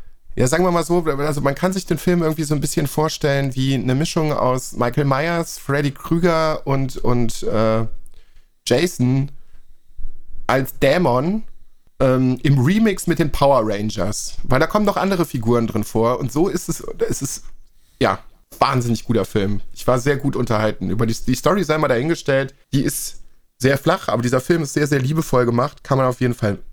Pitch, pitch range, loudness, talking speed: 135 Hz, 125-160 Hz, -19 LUFS, 190 wpm